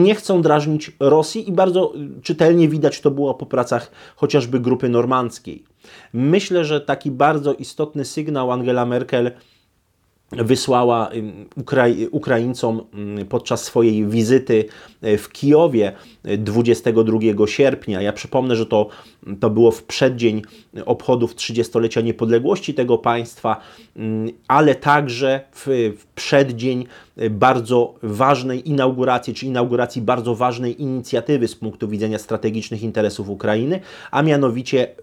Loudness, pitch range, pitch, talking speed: -18 LUFS, 115-140 Hz, 125 Hz, 110 wpm